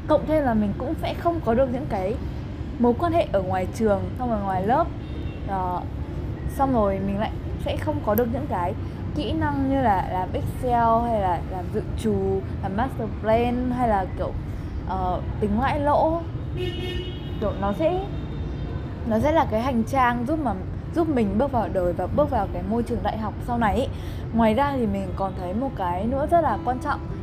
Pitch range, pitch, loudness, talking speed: 220-275 Hz, 240 Hz, -24 LUFS, 205 wpm